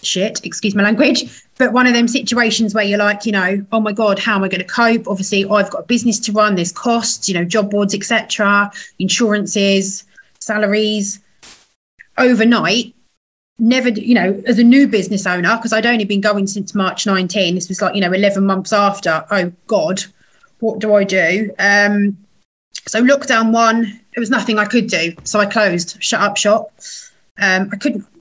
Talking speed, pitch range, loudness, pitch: 190 wpm, 195-230 Hz, -15 LUFS, 210 Hz